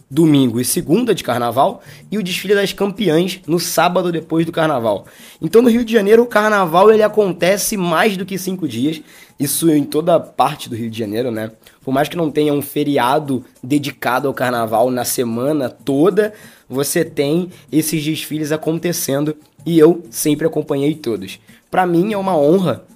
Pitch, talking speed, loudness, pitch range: 155 Hz, 175 wpm, -16 LUFS, 140-180 Hz